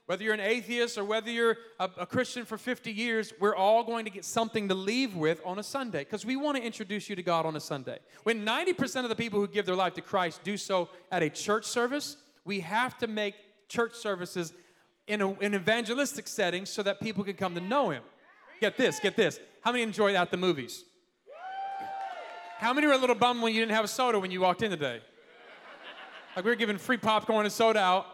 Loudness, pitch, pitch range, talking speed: -30 LUFS, 220 Hz, 190-240 Hz, 230 wpm